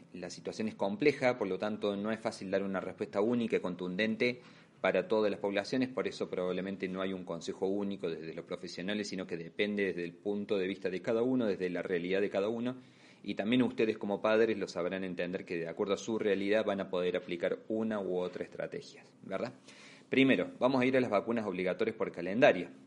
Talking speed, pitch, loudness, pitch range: 215 wpm, 100 Hz, -34 LUFS, 90-110 Hz